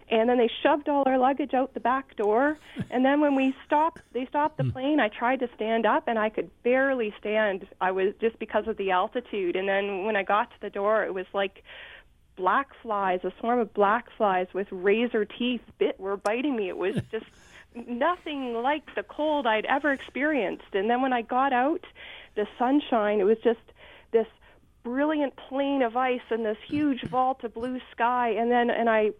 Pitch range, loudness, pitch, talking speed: 210-270 Hz, -26 LUFS, 240 Hz, 205 wpm